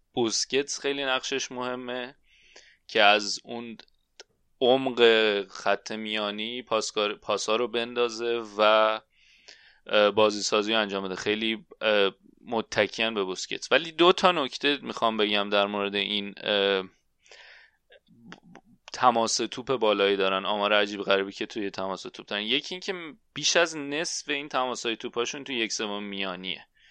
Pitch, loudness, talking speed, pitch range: 110 Hz, -26 LUFS, 125 wpm, 100-125 Hz